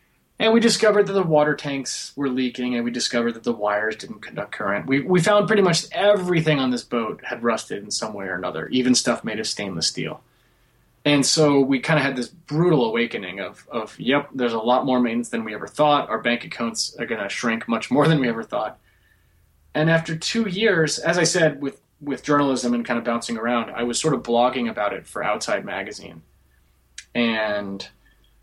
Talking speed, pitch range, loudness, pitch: 210 wpm, 115-160 Hz, -22 LUFS, 130 Hz